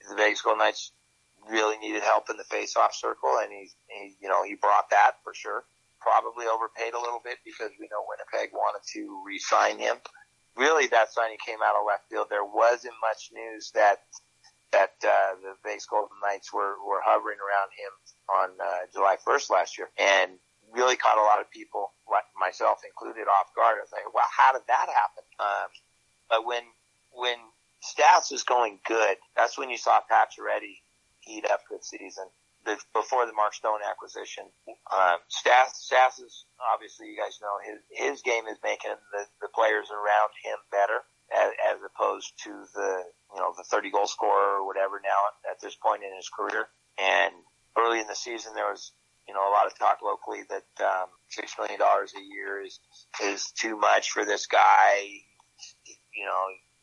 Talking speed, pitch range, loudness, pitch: 185 wpm, 100-125 Hz, -26 LUFS, 110 Hz